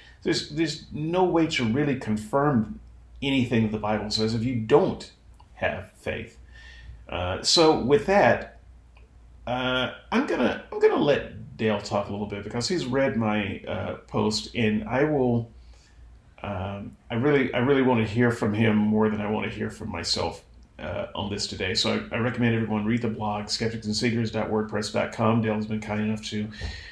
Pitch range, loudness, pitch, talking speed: 105-125 Hz, -25 LUFS, 110 Hz, 170 wpm